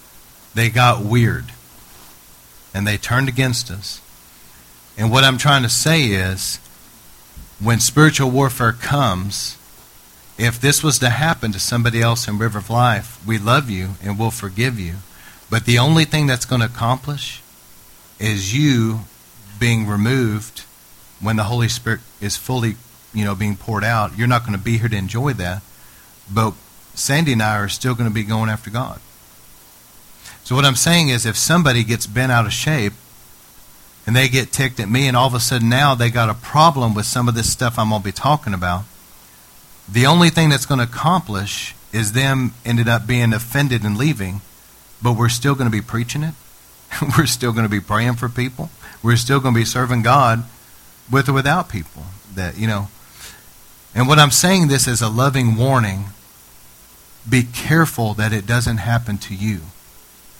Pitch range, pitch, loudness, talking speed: 100-130 Hz, 115 Hz, -17 LUFS, 180 wpm